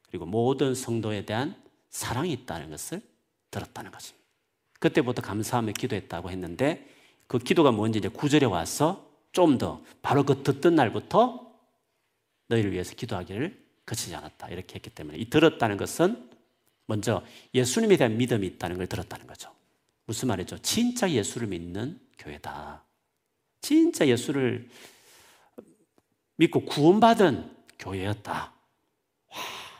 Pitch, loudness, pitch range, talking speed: 120 Hz, -26 LUFS, 105-160 Hz, 295 characters per minute